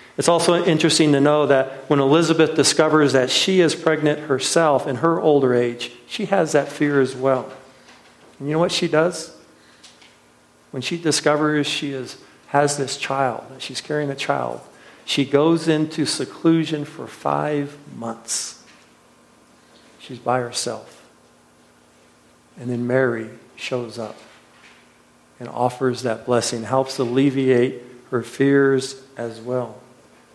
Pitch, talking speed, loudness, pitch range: 135 Hz, 130 wpm, -20 LUFS, 125-150 Hz